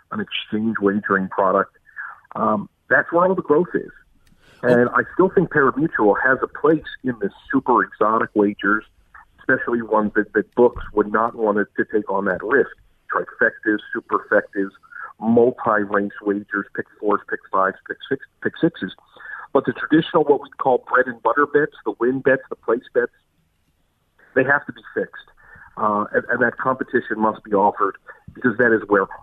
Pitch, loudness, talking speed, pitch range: 120 Hz, -20 LUFS, 170 wpm, 105-155 Hz